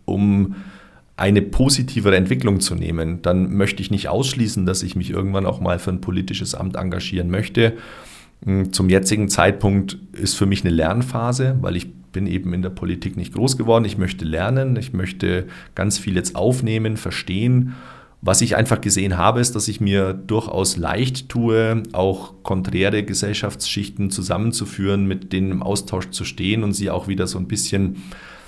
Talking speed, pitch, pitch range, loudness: 170 wpm, 100 Hz, 95-110 Hz, -20 LUFS